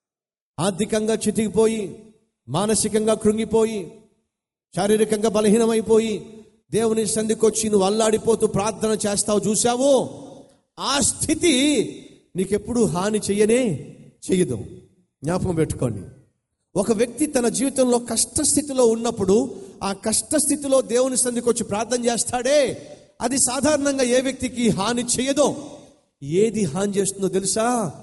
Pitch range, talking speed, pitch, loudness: 205-245 Hz, 90 wpm, 220 Hz, -21 LUFS